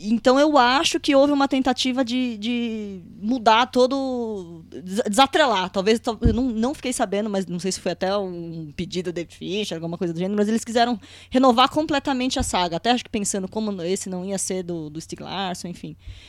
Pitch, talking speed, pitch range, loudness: 220 Hz, 195 wpm, 185-255 Hz, -22 LUFS